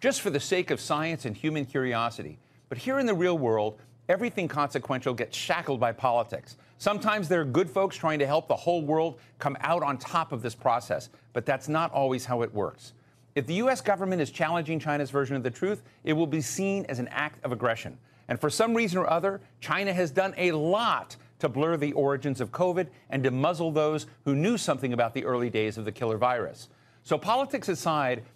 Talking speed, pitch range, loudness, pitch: 215 wpm, 125-180 Hz, -28 LUFS, 145 Hz